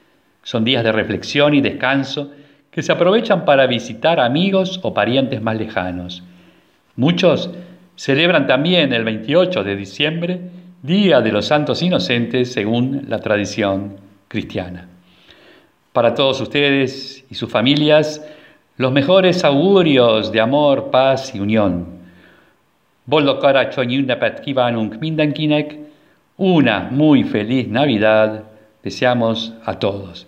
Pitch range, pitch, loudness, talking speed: 110-150 Hz, 130 Hz, -16 LUFS, 105 wpm